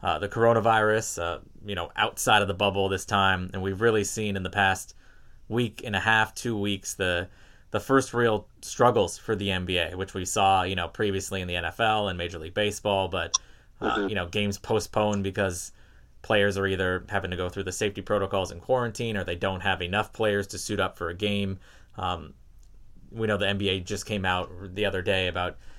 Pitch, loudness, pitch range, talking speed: 100 Hz, -27 LUFS, 90-105 Hz, 205 wpm